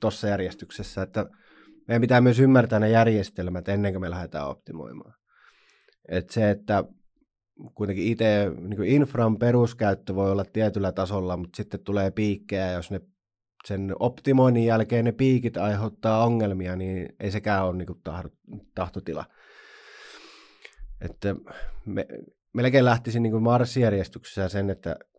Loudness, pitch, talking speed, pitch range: -25 LUFS, 105 Hz, 130 wpm, 95-115 Hz